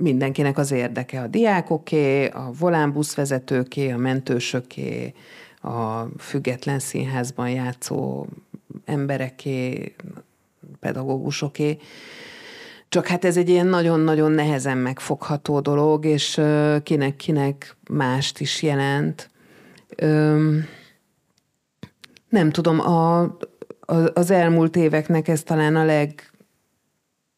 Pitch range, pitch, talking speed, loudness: 135-160 Hz, 150 Hz, 85 wpm, -21 LUFS